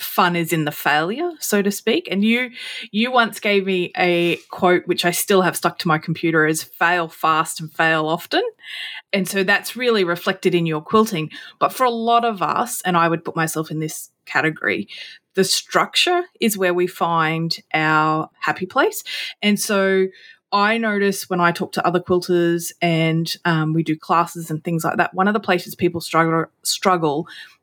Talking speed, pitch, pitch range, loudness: 190 wpm, 180 Hz, 165-205 Hz, -19 LUFS